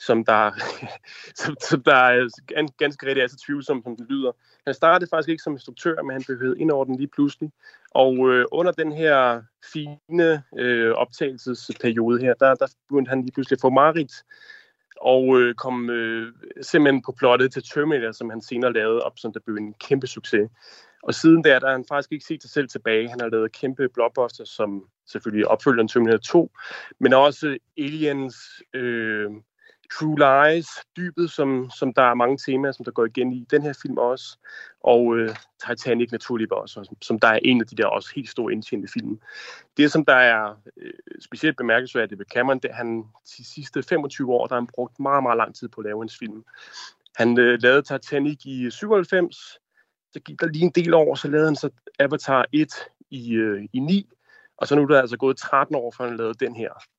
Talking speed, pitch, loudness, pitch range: 205 wpm, 130 Hz, -21 LUFS, 120-150 Hz